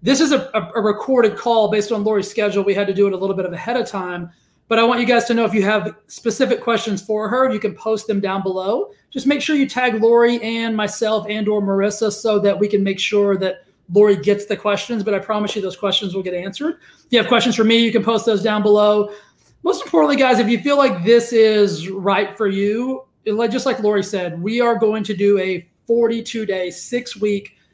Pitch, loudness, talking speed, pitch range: 215 Hz, -18 LUFS, 240 wpm, 200-235 Hz